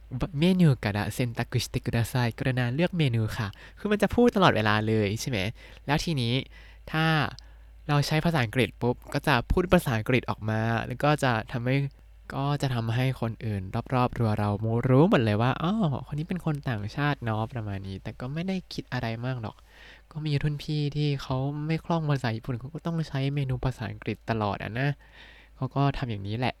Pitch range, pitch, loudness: 115-145 Hz, 130 Hz, -27 LUFS